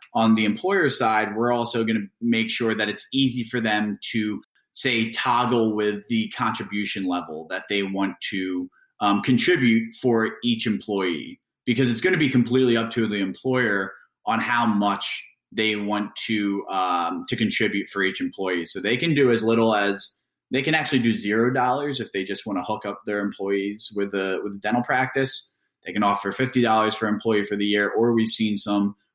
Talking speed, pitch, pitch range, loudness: 195 wpm, 110 Hz, 100-120 Hz, -23 LUFS